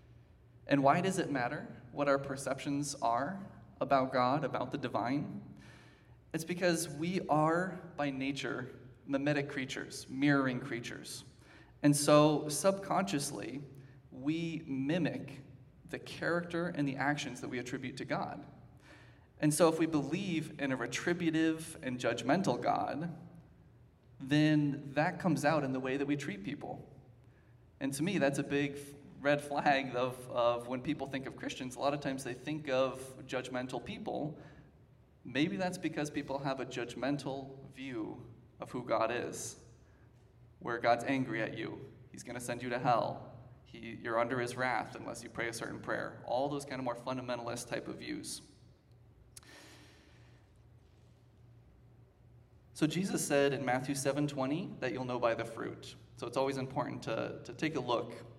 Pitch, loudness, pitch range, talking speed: 135 Hz, -35 LUFS, 125-145 Hz, 155 wpm